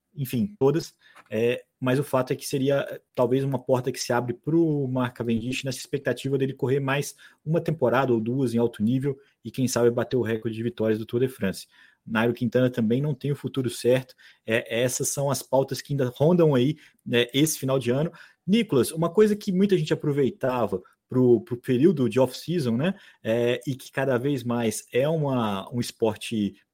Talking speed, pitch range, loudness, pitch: 200 wpm, 120-140 Hz, -25 LUFS, 130 Hz